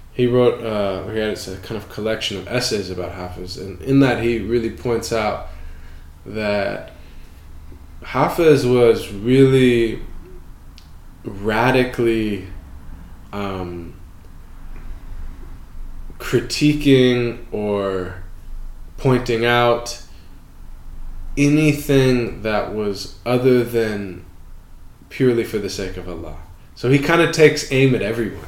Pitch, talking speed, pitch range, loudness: 105 Hz, 105 wpm, 90-120 Hz, -18 LUFS